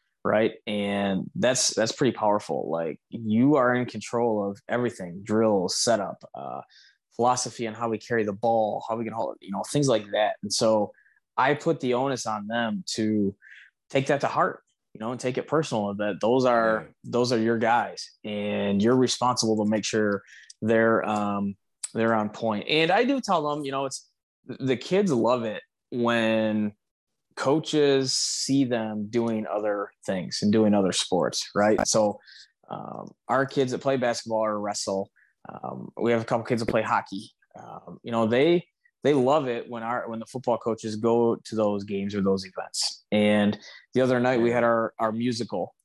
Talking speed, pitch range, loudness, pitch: 185 wpm, 105-125 Hz, -25 LUFS, 115 Hz